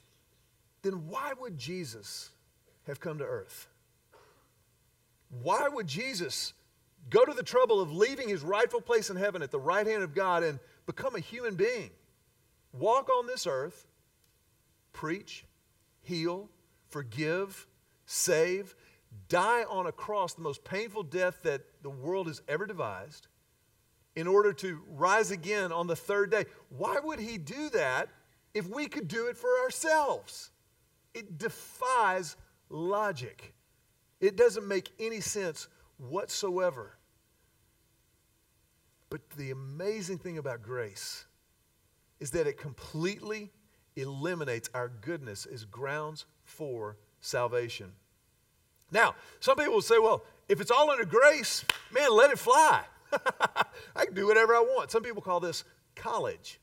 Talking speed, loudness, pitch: 135 wpm, -30 LUFS, 200 Hz